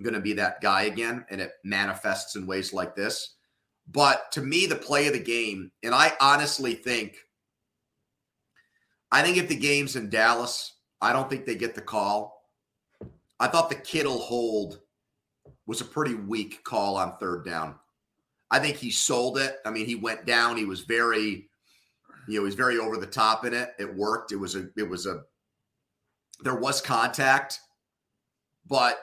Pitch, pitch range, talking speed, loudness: 110 Hz, 105-120 Hz, 180 wpm, -26 LUFS